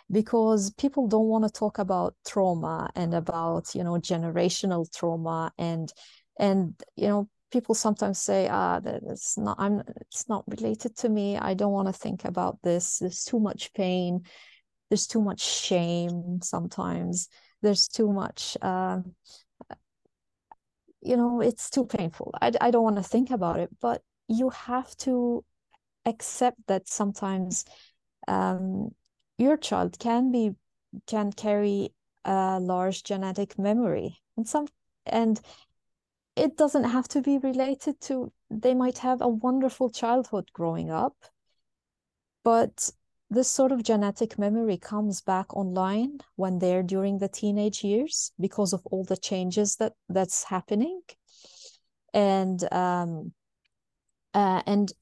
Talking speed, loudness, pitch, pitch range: 140 wpm, -27 LUFS, 205 Hz, 185-235 Hz